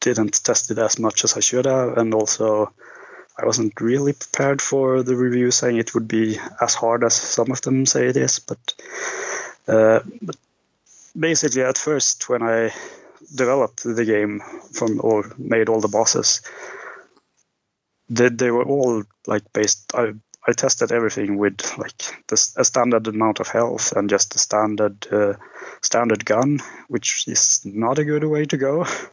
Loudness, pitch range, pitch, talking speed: -19 LUFS, 110-130 Hz, 115 Hz, 165 wpm